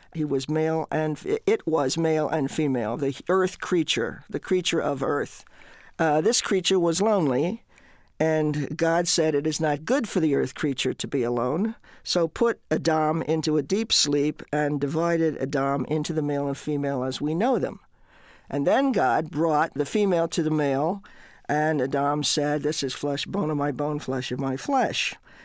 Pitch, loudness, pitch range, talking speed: 155 Hz, -25 LUFS, 145-165 Hz, 180 wpm